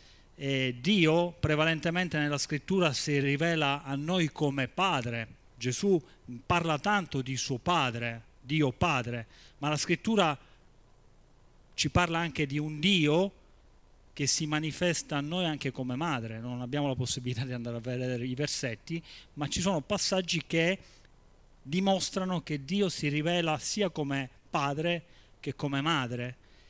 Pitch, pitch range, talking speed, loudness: 150 Hz, 125-170 Hz, 140 wpm, -30 LUFS